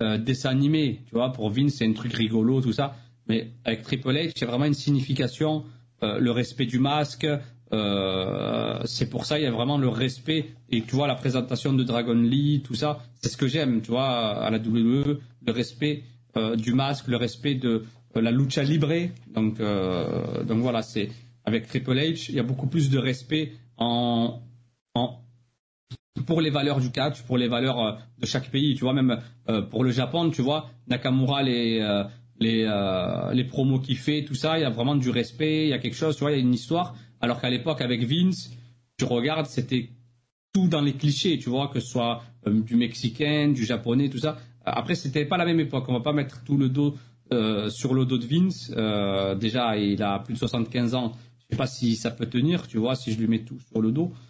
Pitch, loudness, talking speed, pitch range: 125 Hz, -26 LUFS, 220 wpm, 120-140 Hz